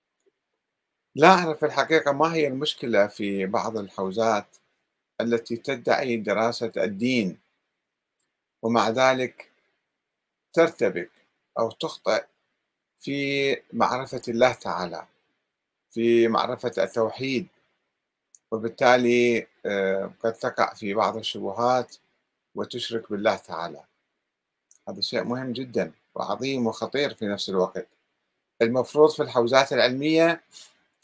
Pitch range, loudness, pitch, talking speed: 115-135 Hz, -24 LUFS, 120 Hz, 90 wpm